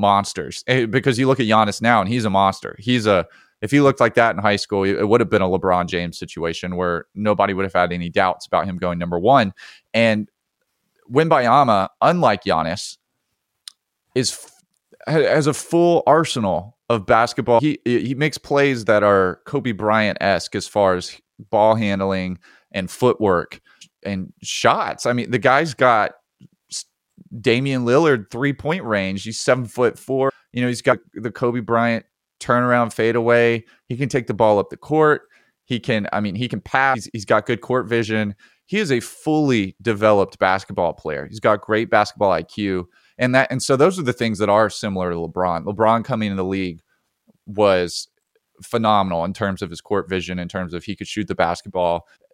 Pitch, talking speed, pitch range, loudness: 110 Hz, 180 wpm, 95-125 Hz, -19 LUFS